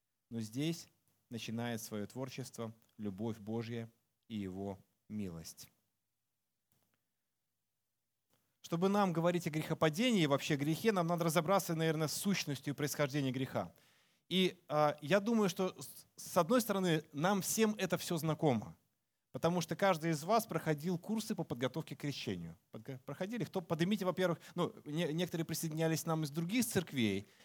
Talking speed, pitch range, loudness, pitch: 140 wpm, 115-175 Hz, -36 LUFS, 155 Hz